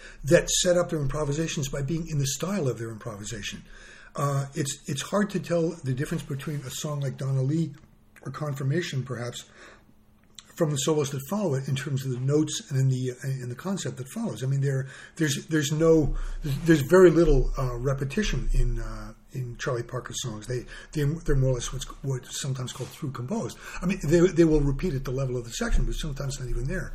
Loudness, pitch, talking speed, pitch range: -27 LUFS, 140 Hz, 215 wpm, 130-160 Hz